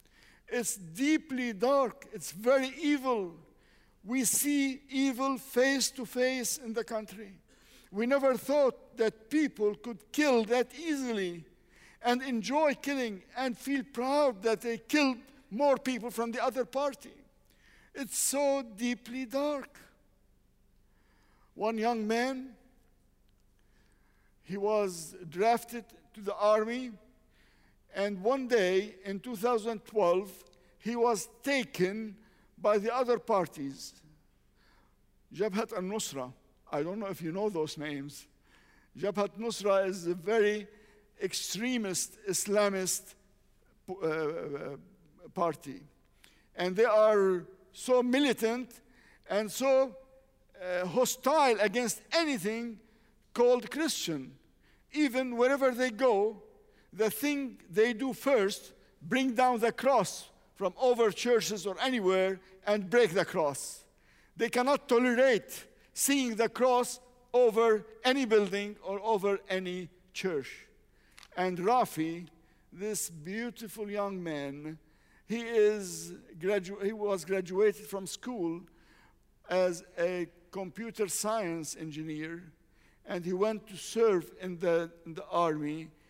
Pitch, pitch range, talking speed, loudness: 220 Hz, 185-250 Hz, 110 wpm, -31 LUFS